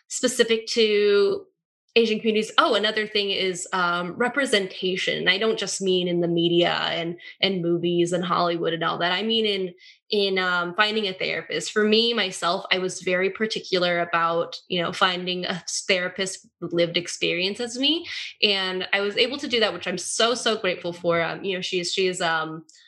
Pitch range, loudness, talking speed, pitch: 175-220 Hz, -23 LUFS, 185 wpm, 190 Hz